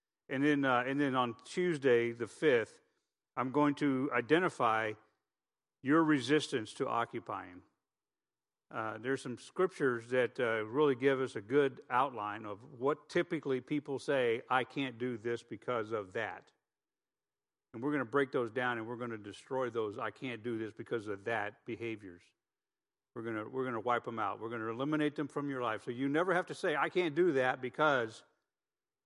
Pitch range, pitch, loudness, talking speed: 115-145 Hz, 125 Hz, -34 LUFS, 185 wpm